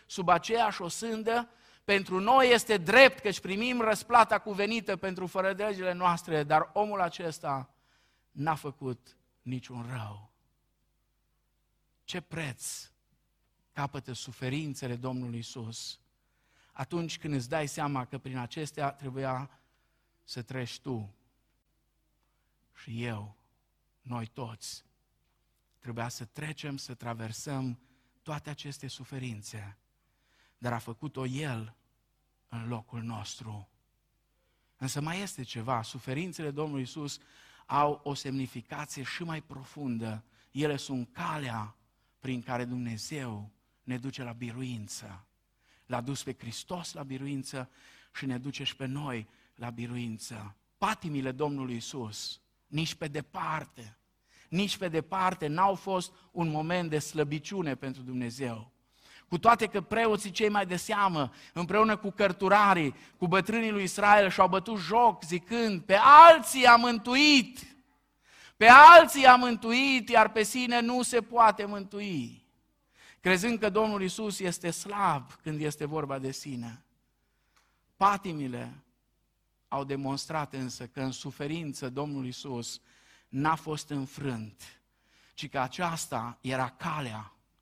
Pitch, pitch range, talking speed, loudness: 140 Hz, 125-185 Hz, 120 wpm, -26 LUFS